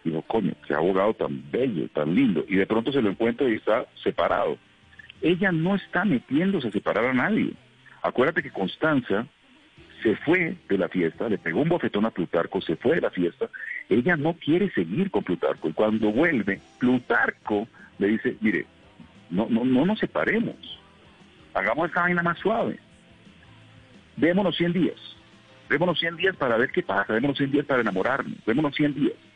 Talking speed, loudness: 175 wpm, -25 LUFS